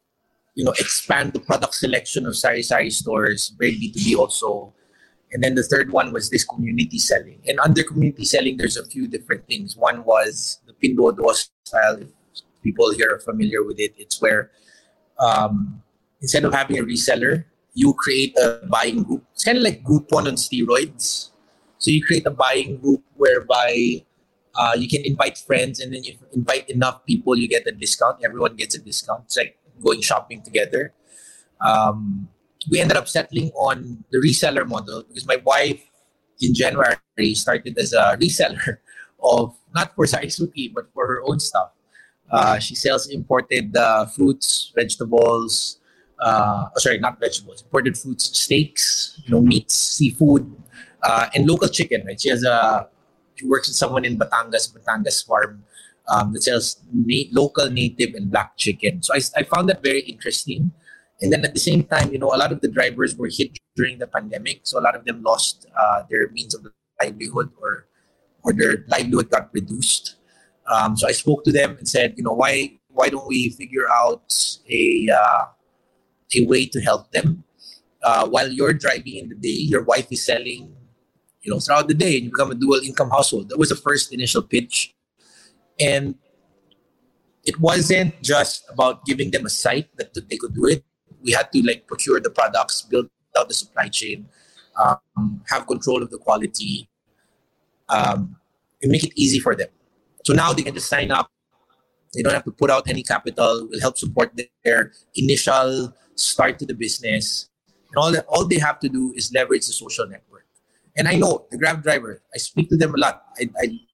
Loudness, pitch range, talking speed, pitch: -20 LUFS, 125-165 Hz, 185 wpm, 140 Hz